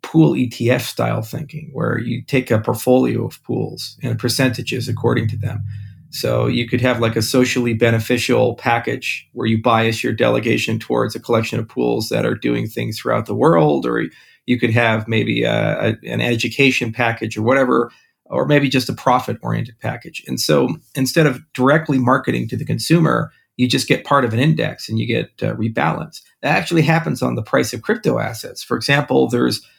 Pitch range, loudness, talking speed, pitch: 115-135 Hz, -18 LUFS, 185 wpm, 120 Hz